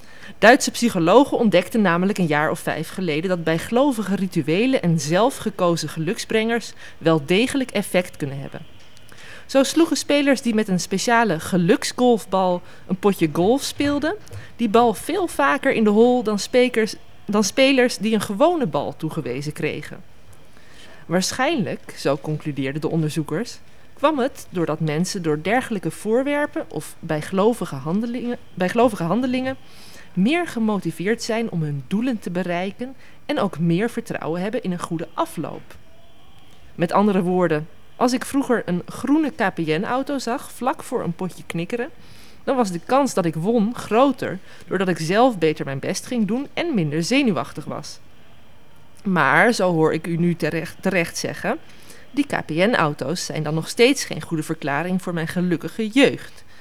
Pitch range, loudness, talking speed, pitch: 165-245 Hz, -21 LUFS, 145 wpm, 195 Hz